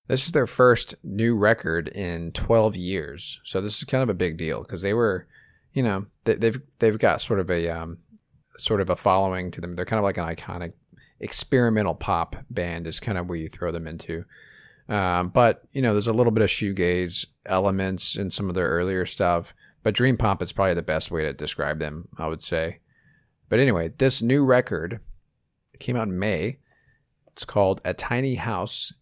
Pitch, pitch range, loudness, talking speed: 100 Hz, 90-115 Hz, -24 LUFS, 205 wpm